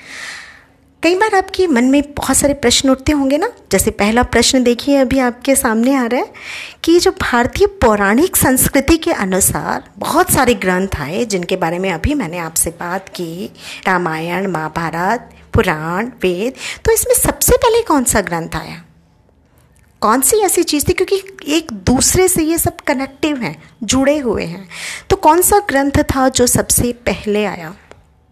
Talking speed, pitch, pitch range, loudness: 165 wpm, 260 Hz, 195-320 Hz, -14 LUFS